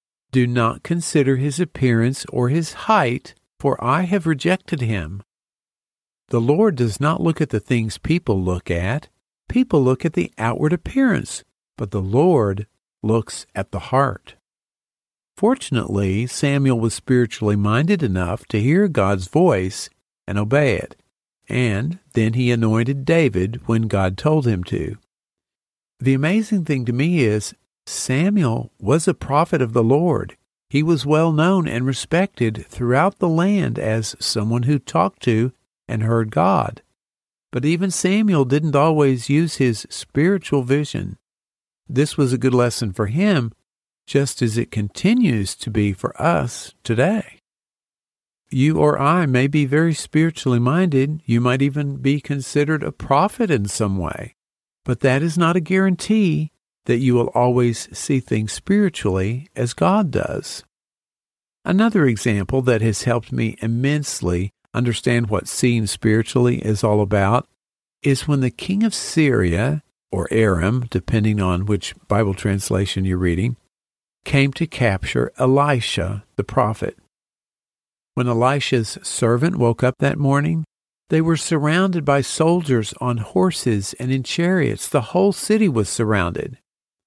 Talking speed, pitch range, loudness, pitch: 140 wpm, 110-155 Hz, -19 LUFS, 130 Hz